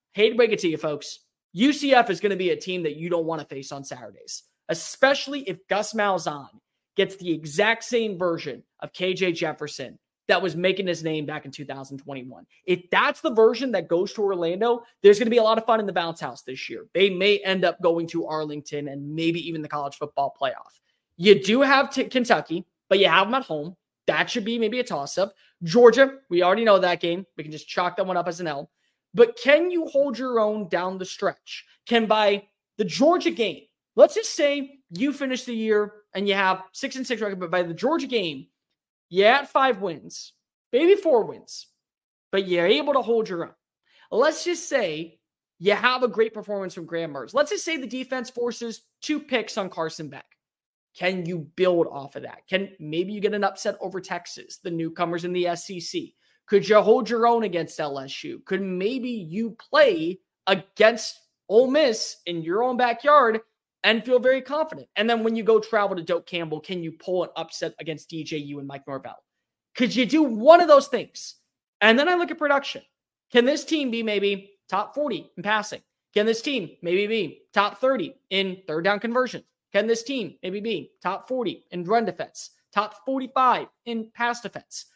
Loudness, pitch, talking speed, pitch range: -23 LUFS, 200 Hz, 205 wpm, 175-245 Hz